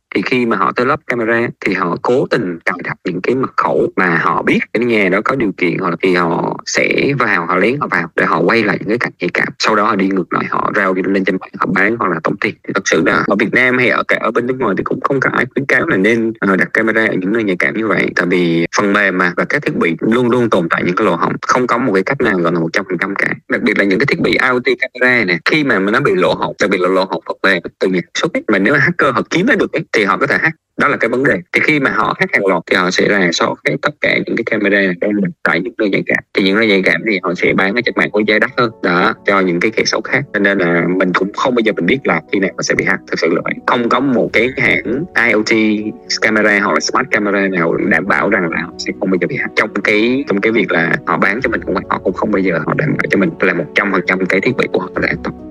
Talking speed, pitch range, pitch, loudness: 320 wpm, 90-110 Hz, 100 Hz, -14 LUFS